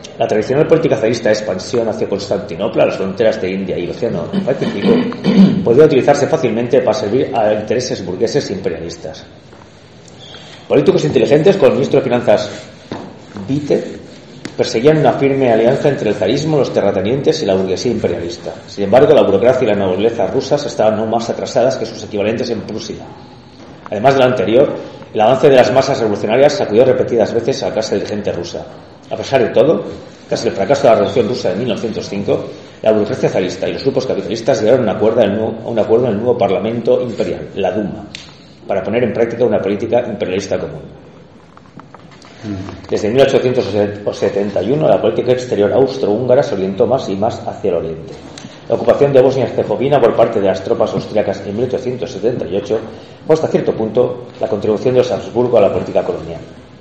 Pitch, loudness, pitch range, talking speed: 120 Hz, -14 LUFS, 100-135 Hz, 170 wpm